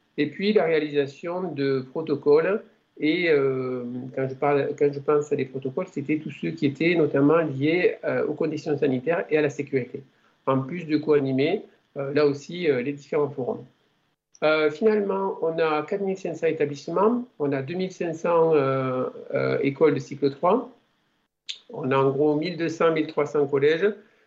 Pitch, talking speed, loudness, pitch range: 150 Hz, 160 wpm, -24 LUFS, 140-170 Hz